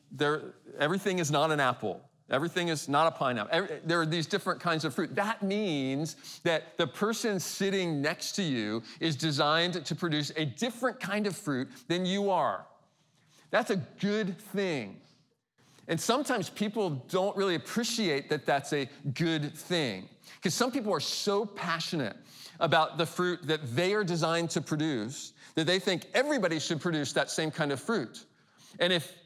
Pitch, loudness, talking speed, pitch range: 170 Hz, -30 LUFS, 170 wpm, 155-195 Hz